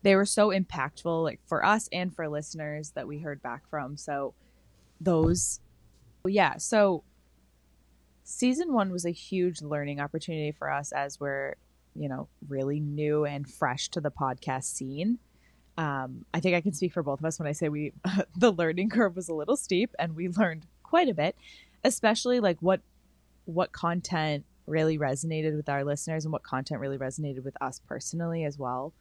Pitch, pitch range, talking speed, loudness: 155 Hz, 140-180 Hz, 180 wpm, -29 LUFS